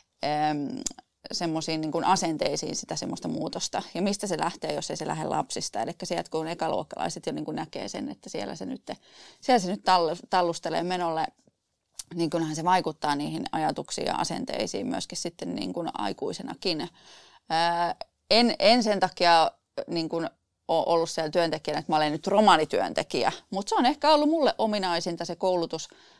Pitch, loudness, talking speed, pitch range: 170 Hz, -27 LUFS, 145 wpm, 160-200 Hz